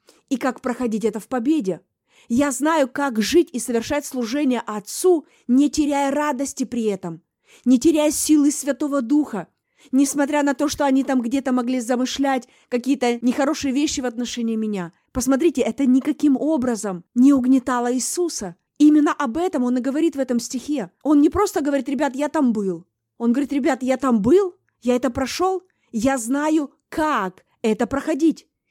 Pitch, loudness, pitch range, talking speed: 270 Hz, -21 LUFS, 245-295 Hz, 160 wpm